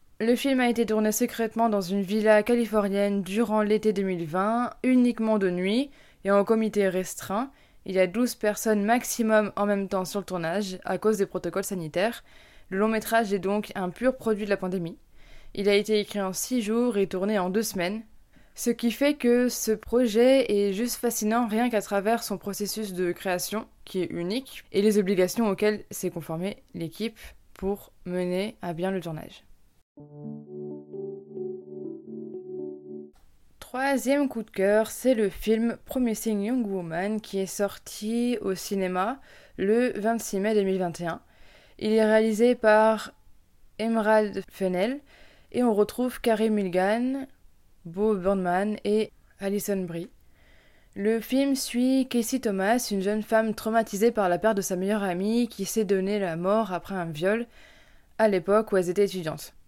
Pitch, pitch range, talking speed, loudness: 210 Hz, 190-230 Hz, 160 wpm, -26 LUFS